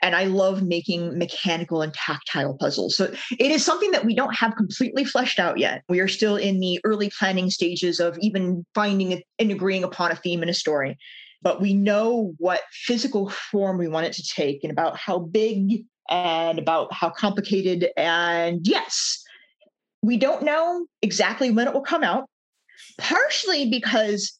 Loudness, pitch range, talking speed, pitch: -23 LUFS, 175-235 Hz, 175 wpm, 200 Hz